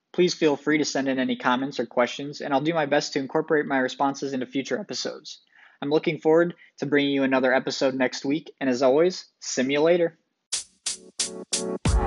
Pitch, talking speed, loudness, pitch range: 140 Hz, 180 wpm, -24 LUFS, 130-155 Hz